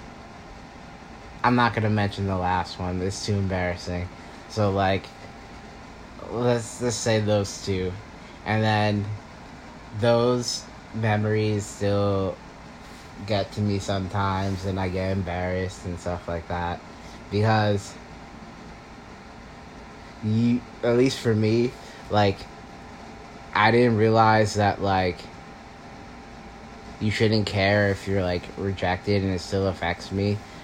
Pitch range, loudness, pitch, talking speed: 90-110 Hz, -24 LUFS, 100 Hz, 115 wpm